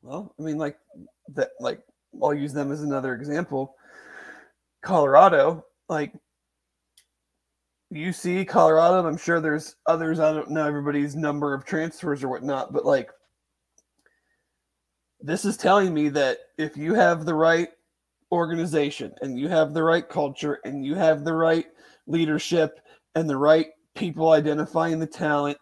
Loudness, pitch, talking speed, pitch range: -23 LUFS, 155 Hz, 150 wpm, 145-165 Hz